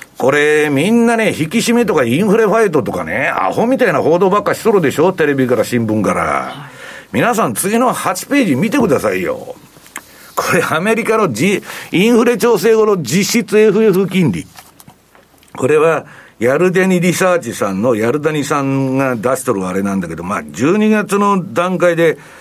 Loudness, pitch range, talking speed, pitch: -13 LUFS, 150-225 Hz, 330 characters per minute, 190 Hz